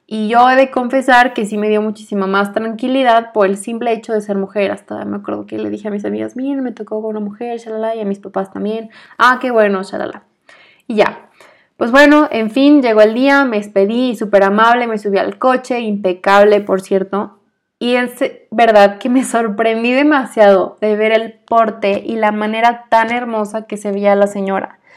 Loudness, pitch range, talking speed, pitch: -14 LUFS, 200-240 Hz, 205 wpm, 220 Hz